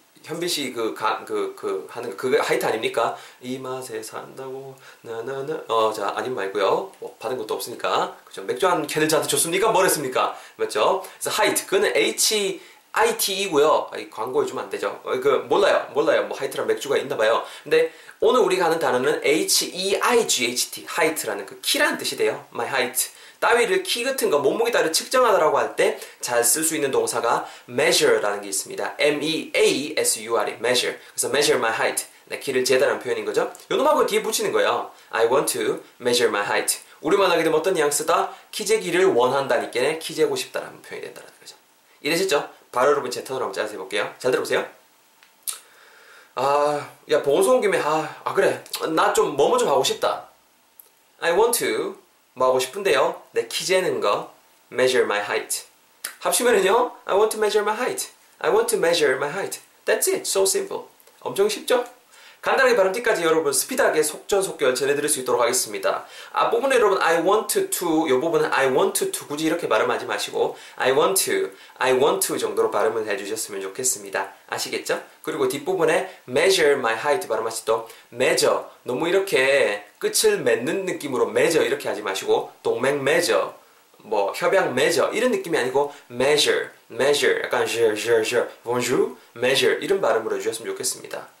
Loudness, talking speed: -22 LUFS, 455 characters per minute